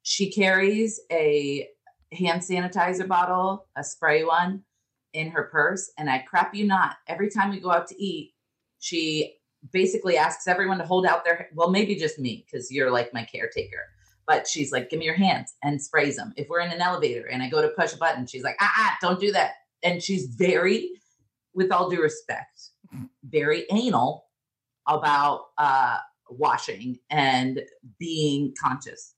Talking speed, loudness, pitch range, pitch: 175 wpm, -24 LUFS, 145-190 Hz, 170 Hz